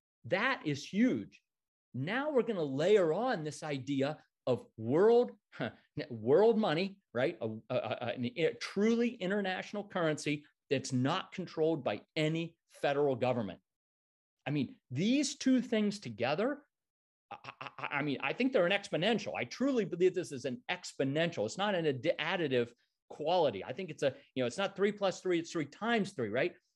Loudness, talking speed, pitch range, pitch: -33 LUFS, 165 wpm, 140-210 Hz, 165 Hz